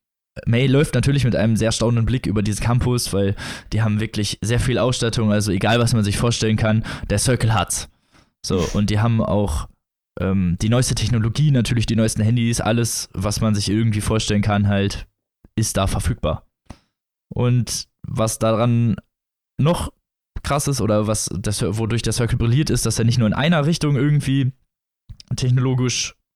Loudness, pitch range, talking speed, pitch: -20 LUFS, 105-120 Hz, 175 wpm, 115 Hz